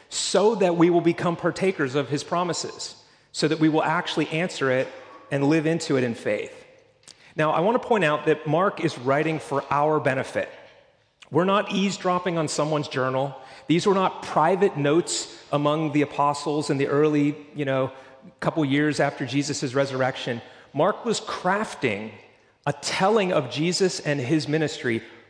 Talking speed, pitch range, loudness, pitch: 165 wpm, 140-175 Hz, -24 LUFS, 155 Hz